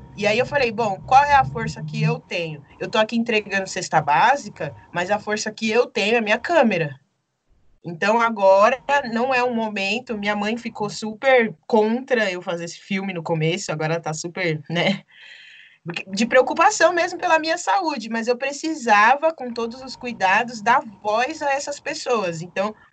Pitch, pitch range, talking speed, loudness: 220 Hz, 180-250 Hz, 180 wpm, -20 LUFS